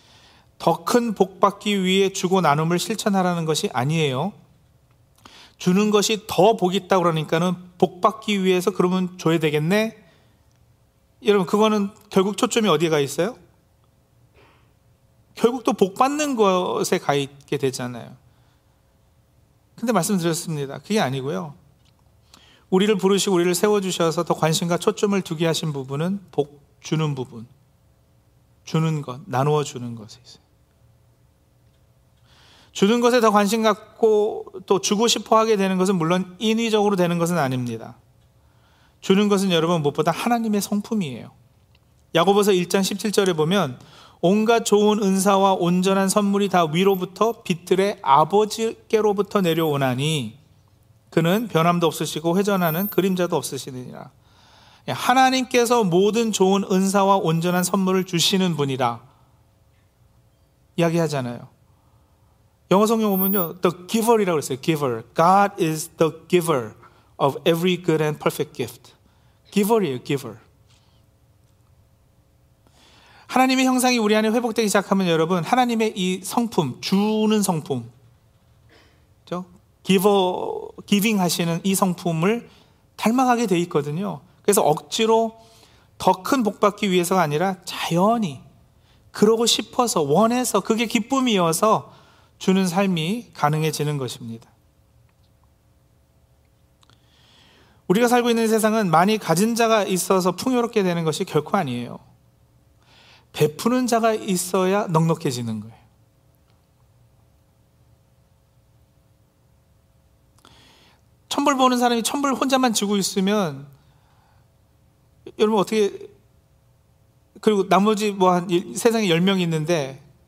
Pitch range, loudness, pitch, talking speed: 145-210 Hz, -20 LUFS, 185 Hz, 285 characters per minute